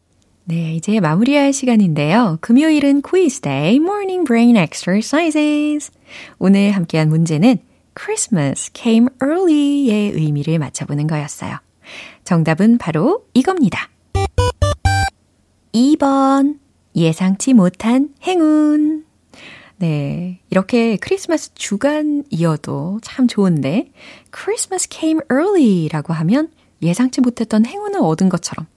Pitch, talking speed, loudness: 230 Hz, 320 characters per minute, -16 LUFS